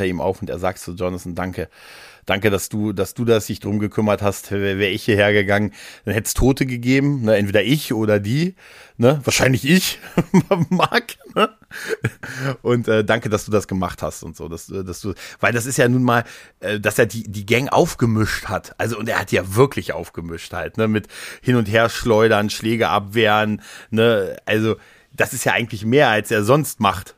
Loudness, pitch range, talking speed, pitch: -19 LUFS, 100-120 Hz, 200 wpm, 110 Hz